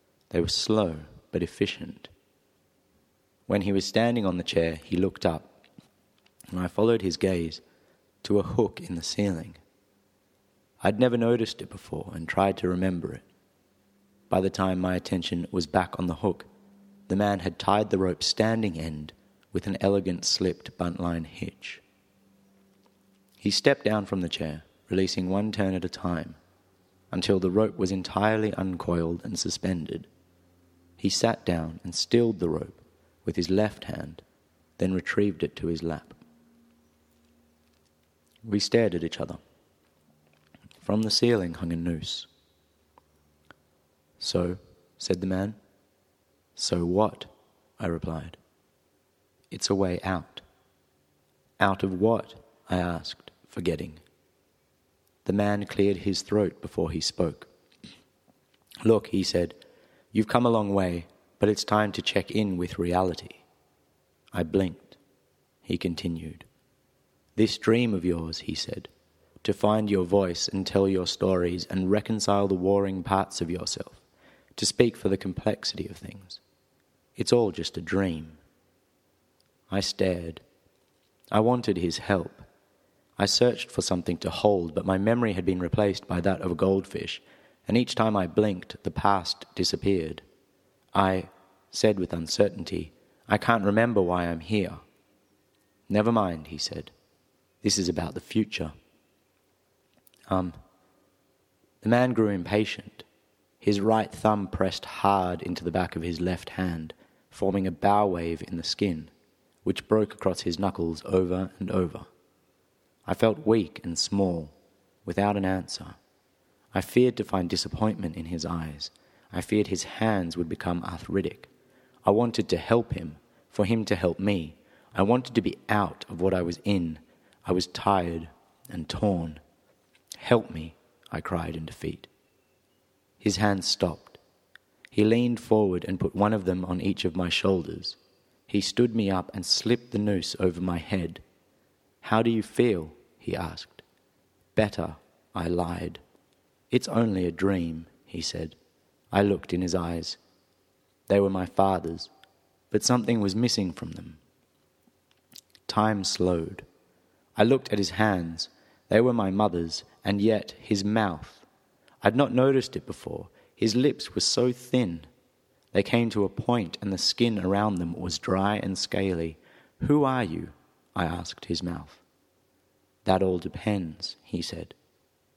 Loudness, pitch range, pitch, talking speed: -27 LUFS, 85-105 Hz, 95 Hz, 145 wpm